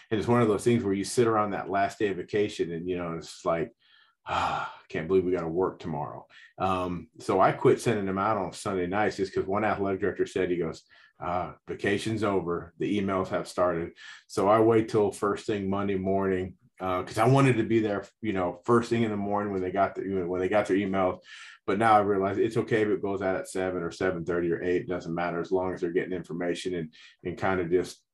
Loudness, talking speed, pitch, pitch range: -28 LUFS, 245 wpm, 95 Hz, 90-105 Hz